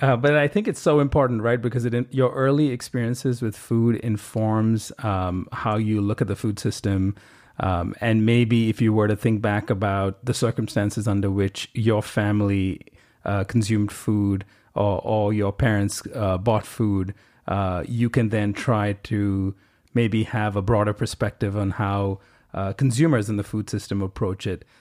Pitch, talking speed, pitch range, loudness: 110 Hz, 170 wpm, 100-120 Hz, -23 LUFS